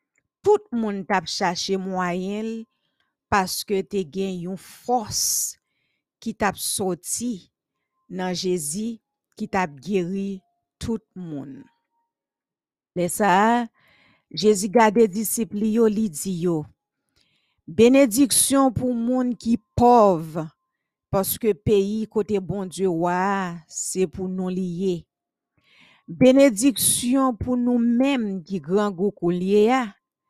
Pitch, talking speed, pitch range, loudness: 205 Hz, 95 wpm, 185-235 Hz, -22 LUFS